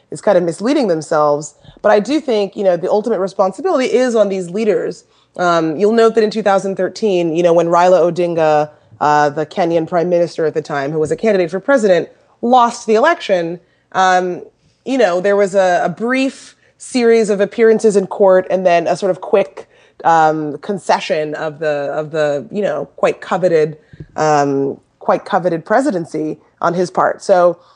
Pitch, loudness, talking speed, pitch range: 180 Hz, -15 LUFS, 185 wpm, 155-210 Hz